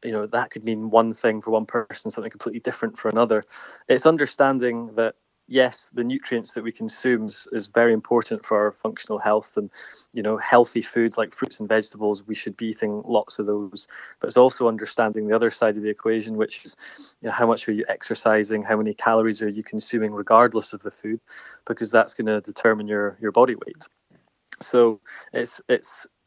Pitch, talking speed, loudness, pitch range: 110 Hz, 200 wpm, -22 LUFS, 105-115 Hz